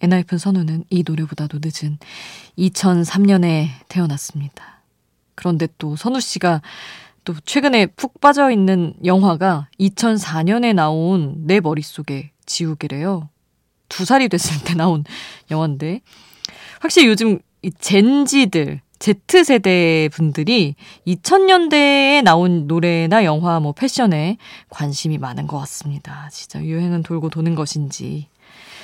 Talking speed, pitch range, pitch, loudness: 250 characters per minute, 155-200 Hz, 175 Hz, -17 LUFS